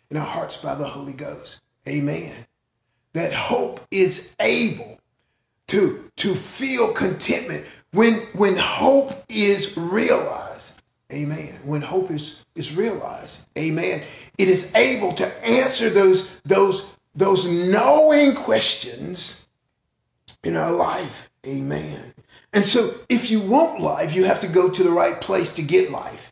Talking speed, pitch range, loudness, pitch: 135 wpm, 150-225 Hz, -20 LUFS, 185 Hz